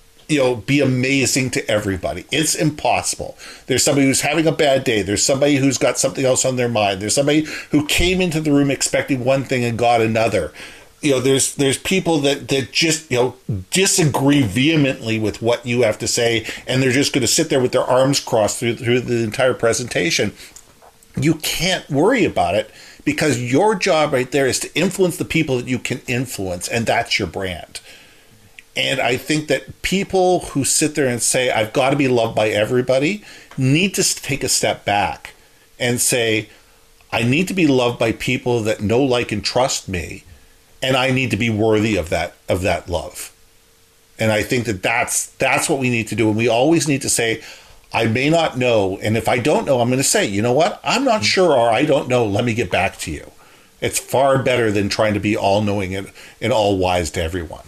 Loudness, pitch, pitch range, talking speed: -18 LUFS, 125 Hz, 110-140 Hz, 210 wpm